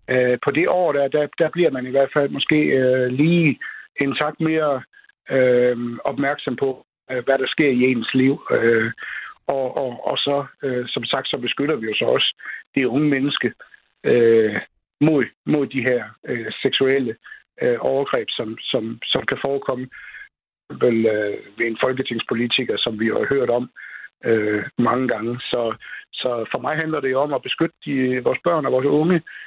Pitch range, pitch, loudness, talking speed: 125-145 Hz, 130 Hz, -20 LUFS, 175 wpm